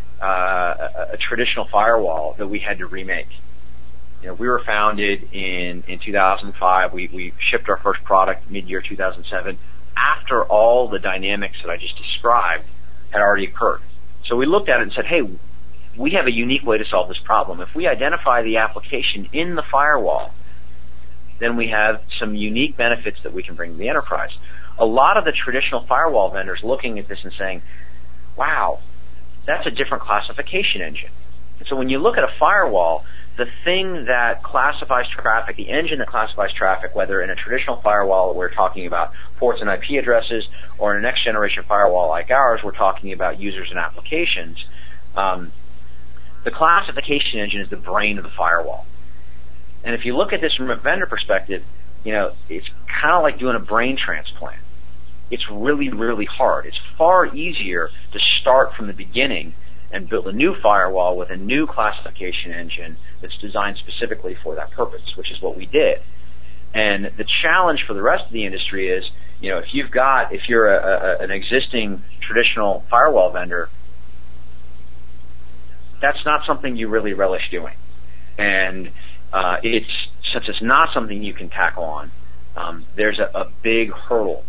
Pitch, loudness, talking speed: 95 Hz, -19 LUFS, 175 wpm